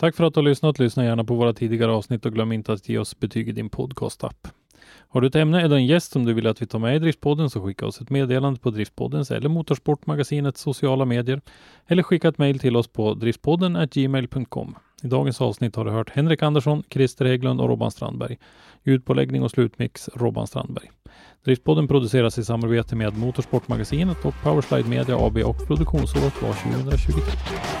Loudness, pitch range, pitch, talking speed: -22 LUFS, 115-145 Hz, 130 Hz, 190 wpm